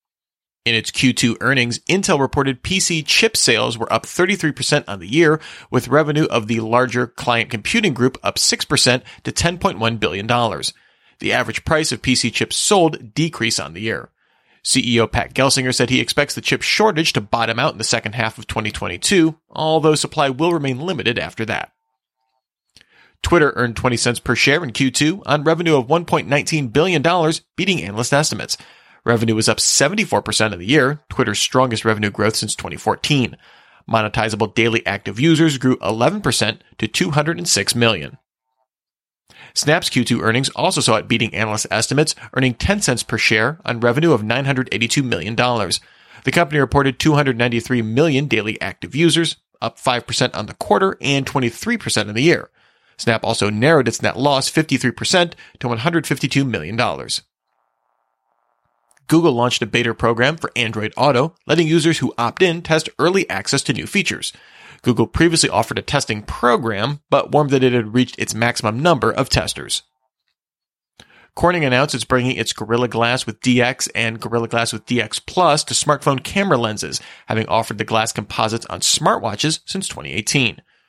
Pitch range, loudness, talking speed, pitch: 115-155 Hz, -17 LUFS, 160 wpm, 130 Hz